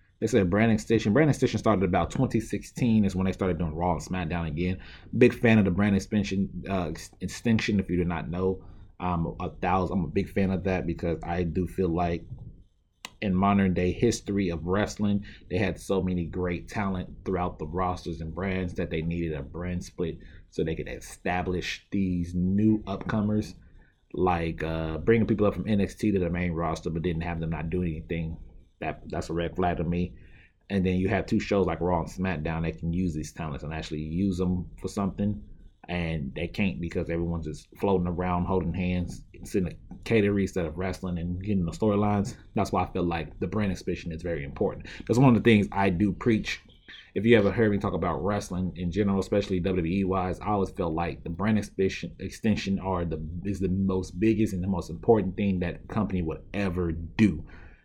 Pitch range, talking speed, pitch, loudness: 85-100 Hz, 205 wpm, 90 Hz, -28 LUFS